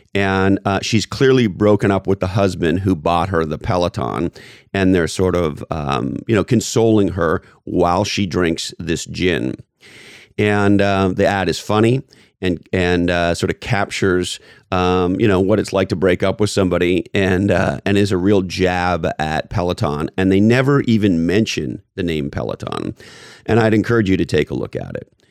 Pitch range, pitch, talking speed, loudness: 90-105 Hz, 95 Hz, 185 wpm, -17 LUFS